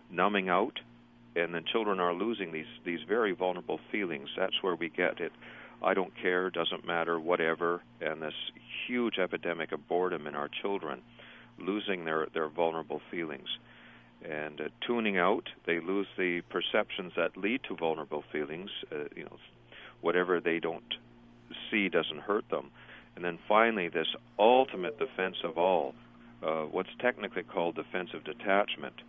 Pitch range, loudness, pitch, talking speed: 60-90 Hz, -32 LUFS, 85 Hz, 155 wpm